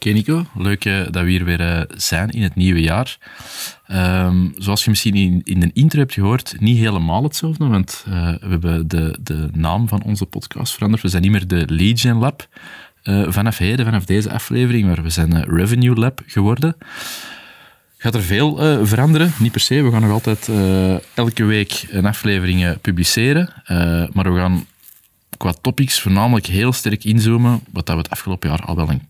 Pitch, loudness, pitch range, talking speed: 100 Hz, -17 LUFS, 90-120 Hz, 195 wpm